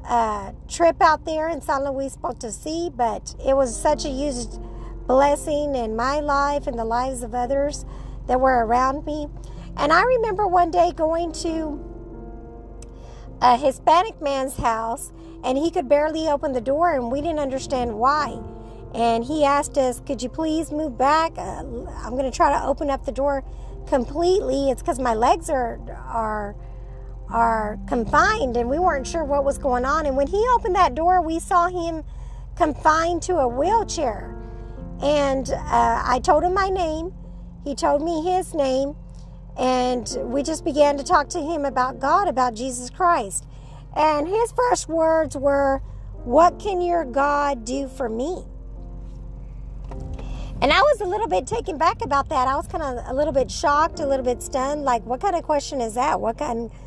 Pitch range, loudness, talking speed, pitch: 250-325 Hz, -22 LUFS, 175 wpm, 280 Hz